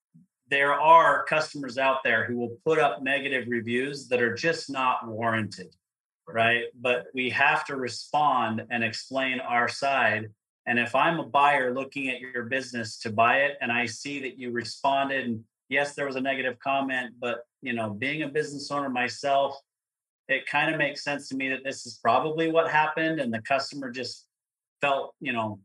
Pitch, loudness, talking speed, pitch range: 130 Hz, -26 LUFS, 185 wpm, 120-140 Hz